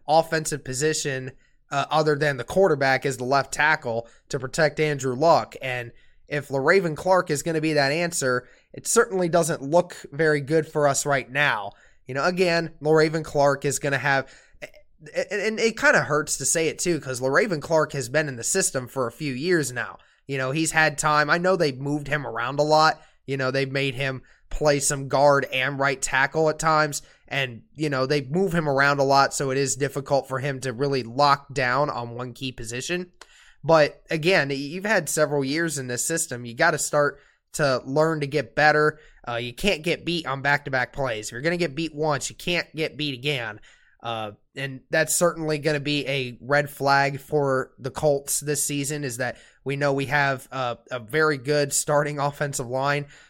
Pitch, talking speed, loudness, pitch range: 145 Hz, 205 wpm, -23 LUFS, 135-155 Hz